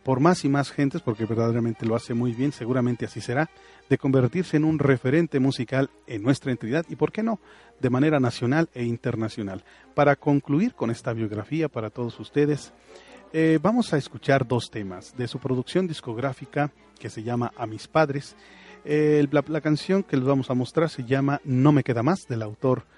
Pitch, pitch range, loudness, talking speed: 135 Hz, 120-150 Hz, -25 LUFS, 190 wpm